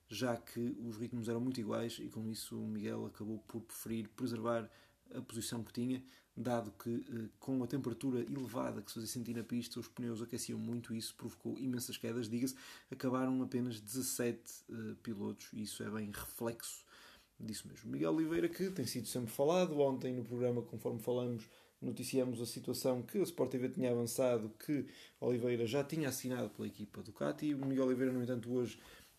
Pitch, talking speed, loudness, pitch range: 120 Hz, 185 wpm, -40 LUFS, 115-130 Hz